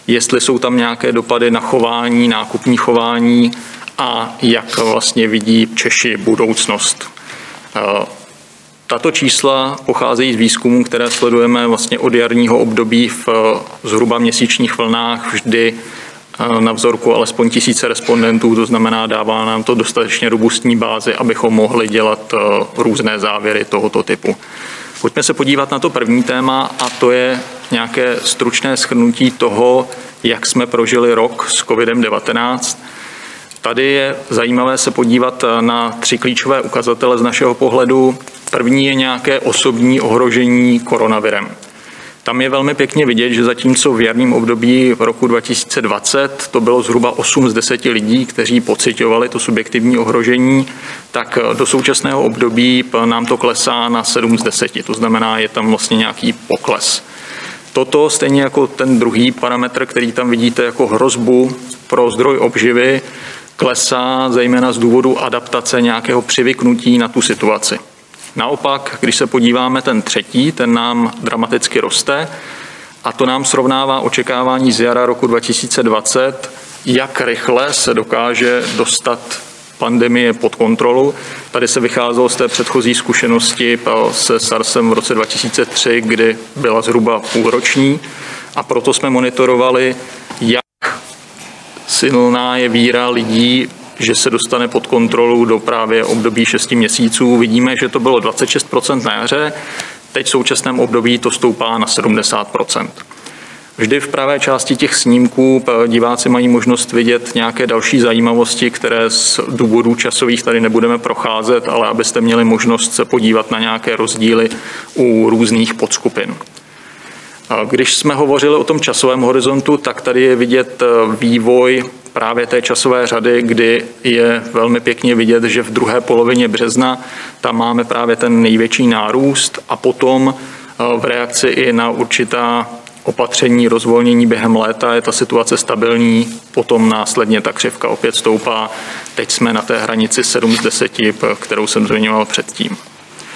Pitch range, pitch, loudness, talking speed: 115-125 Hz, 120 Hz, -12 LUFS, 140 wpm